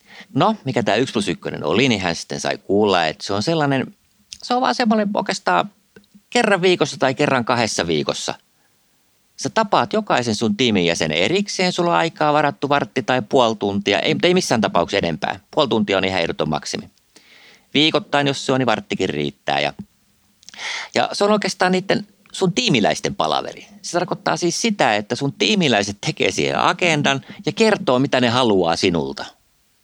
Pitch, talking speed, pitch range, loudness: 145 Hz, 170 wpm, 115-195 Hz, -19 LUFS